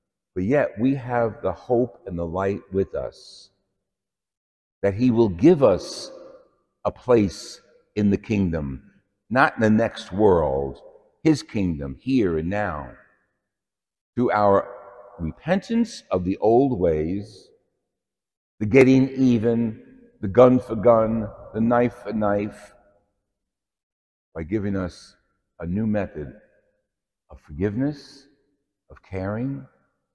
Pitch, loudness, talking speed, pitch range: 105 Hz, -22 LUFS, 115 wpm, 95-125 Hz